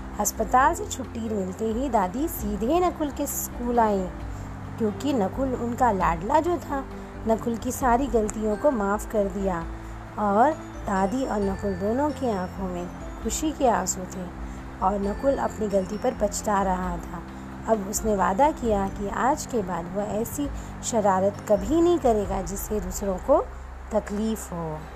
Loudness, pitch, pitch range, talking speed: -25 LUFS, 210 Hz, 195-245 Hz, 155 wpm